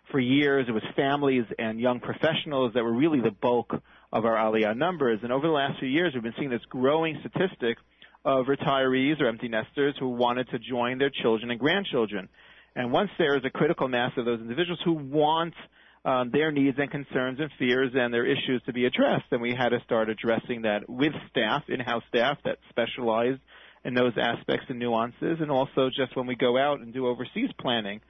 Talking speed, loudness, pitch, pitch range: 205 wpm, -27 LUFS, 130 Hz, 120-140 Hz